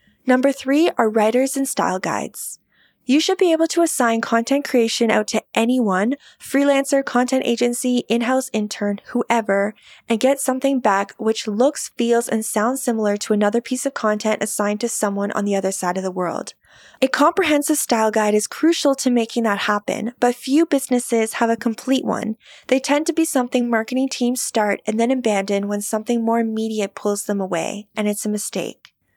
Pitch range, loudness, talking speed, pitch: 215-265 Hz, -20 LUFS, 180 wpm, 235 Hz